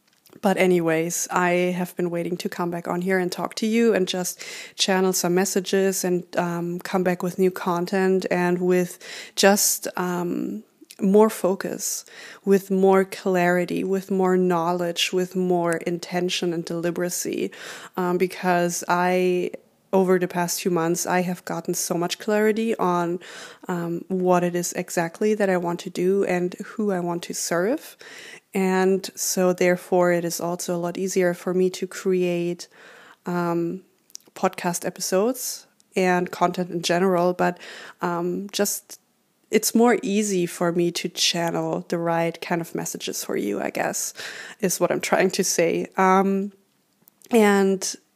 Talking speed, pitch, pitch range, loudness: 150 wpm, 180 Hz, 175-195 Hz, -23 LUFS